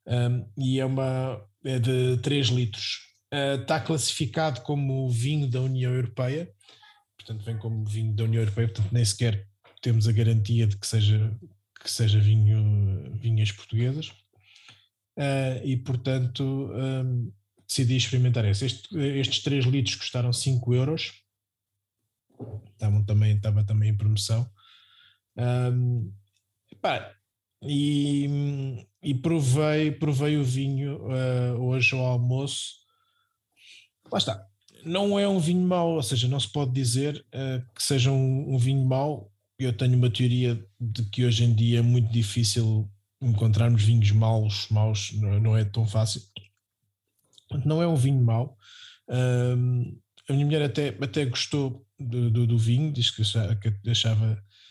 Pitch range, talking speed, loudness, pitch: 110-135 Hz, 140 wpm, -26 LUFS, 120 Hz